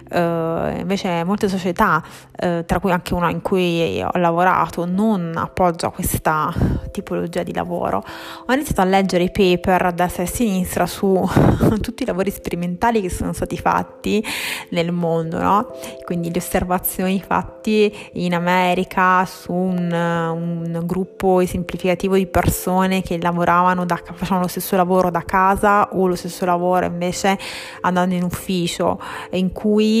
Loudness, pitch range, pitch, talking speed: -19 LUFS, 175-190 Hz, 180 Hz, 145 wpm